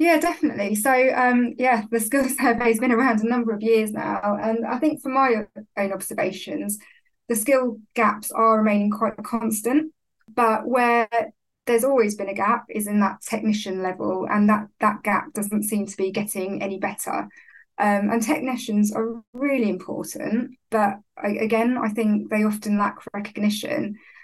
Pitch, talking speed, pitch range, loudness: 225 Hz, 165 wpm, 210-245 Hz, -22 LUFS